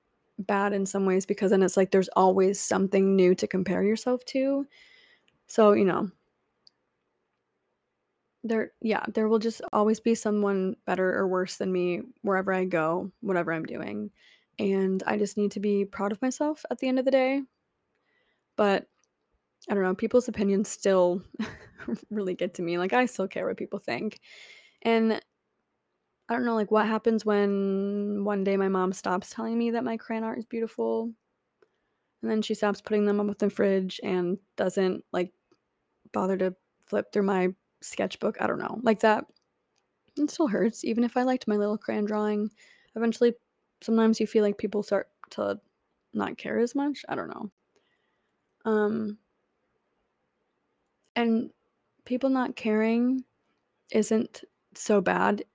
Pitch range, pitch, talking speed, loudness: 195-230 Hz, 210 Hz, 160 wpm, -27 LUFS